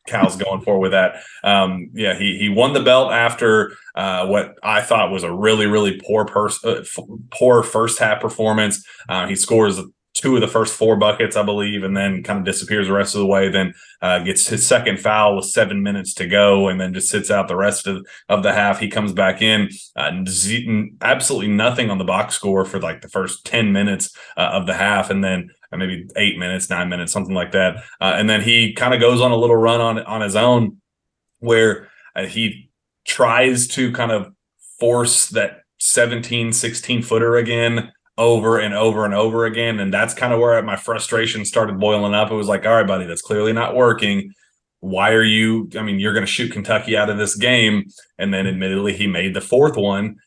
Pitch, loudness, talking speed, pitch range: 105 Hz, -17 LUFS, 215 wpm, 100-115 Hz